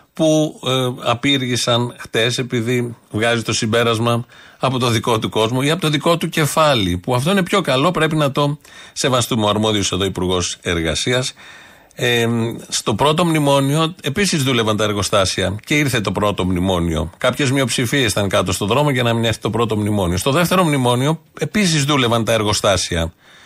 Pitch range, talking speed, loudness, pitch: 105-145 Hz, 170 wpm, -17 LUFS, 120 Hz